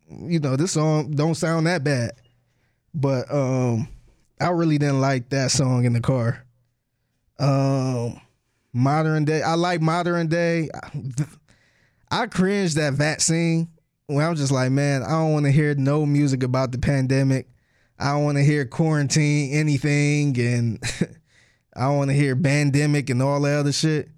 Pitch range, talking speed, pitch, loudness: 130-155 Hz, 160 wpm, 140 Hz, -22 LUFS